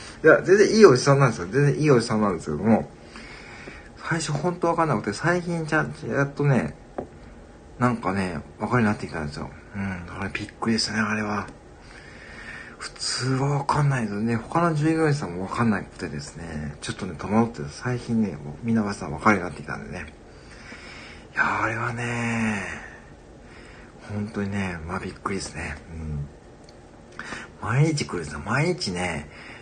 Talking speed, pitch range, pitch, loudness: 350 characters per minute, 85-140 Hz, 105 Hz, -24 LUFS